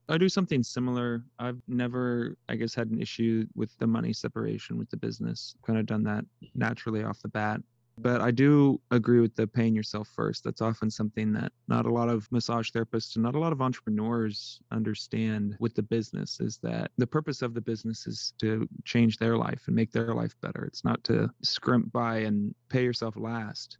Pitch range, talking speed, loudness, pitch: 110-120 Hz, 205 wpm, -29 LUFS, 115 Hz